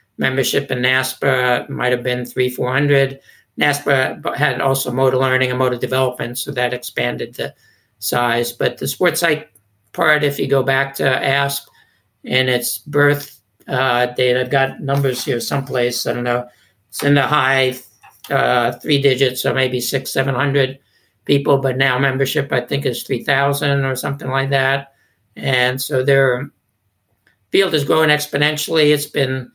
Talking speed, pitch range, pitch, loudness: 160 wpm, 125-140 Hz, 135 Hz, -17 LUFS